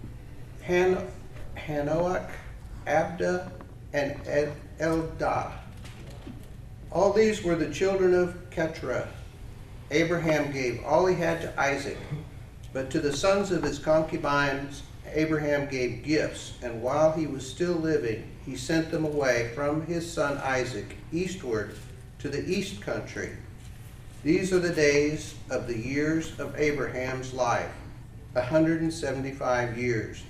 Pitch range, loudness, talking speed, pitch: 120-160 Hz, -28 LUFS, 120 wpm, 140 Hz